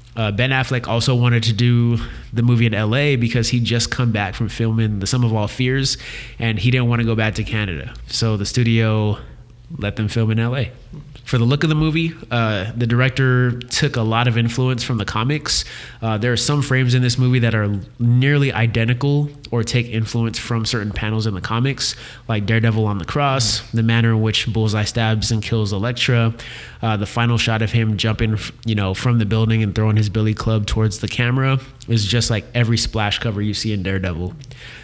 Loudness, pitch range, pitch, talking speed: -19 LUFS, 110-125 Hz, 115 Hz, 210 wpm